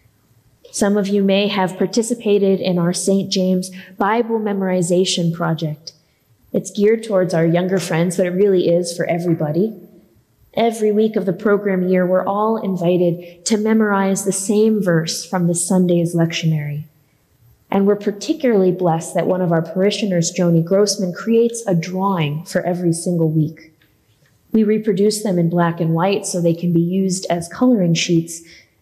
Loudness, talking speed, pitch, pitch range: -17 LUFS, 160 wpm, 185 Hz, 170-200 Hz